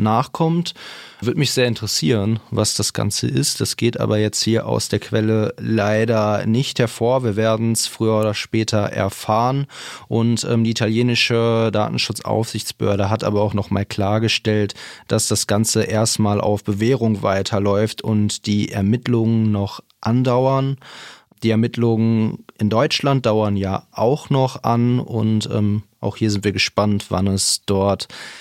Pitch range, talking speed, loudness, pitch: 105-115 Hz, 145 wpm, -19 LUFS, 110 Hz